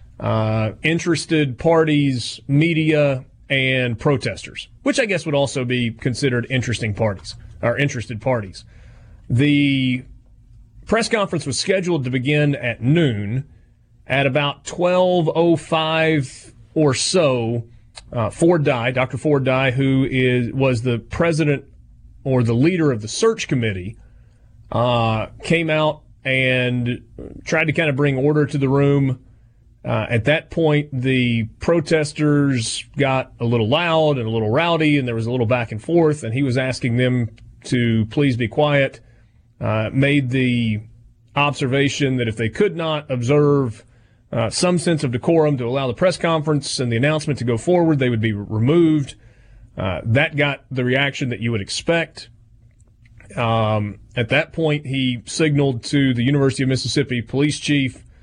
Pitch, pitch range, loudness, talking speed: 130 Hz, 115-150 Hz, -19 LUFS, 150 wpm